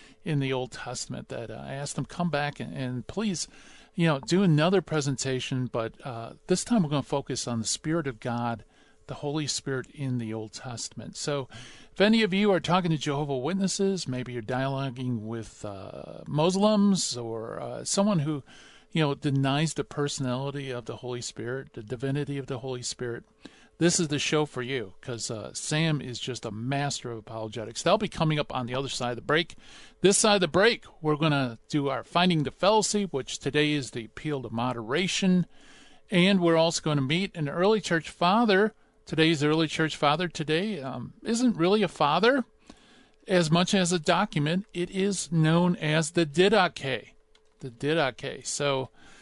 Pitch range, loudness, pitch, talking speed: 130-180 Hz, -27 LUFS, 150 Hz, 190 wpm